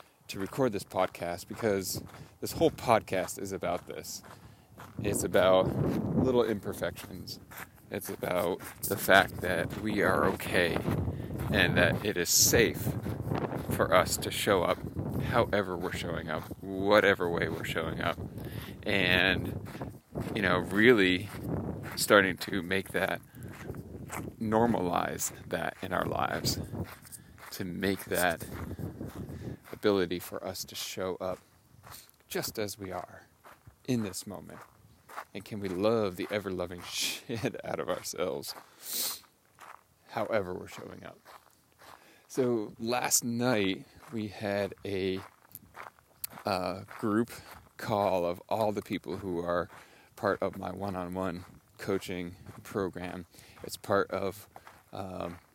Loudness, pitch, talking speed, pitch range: -31 LUFS, 95 Hz, 120 wpm, 90-110 Hz